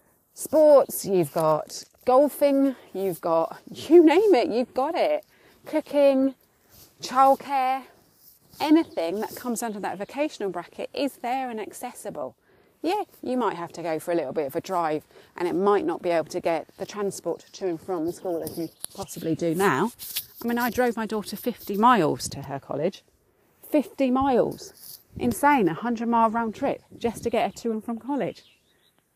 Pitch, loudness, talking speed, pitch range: 235 Hz, -25 LUFS, 175 wpm, 180-275 Hz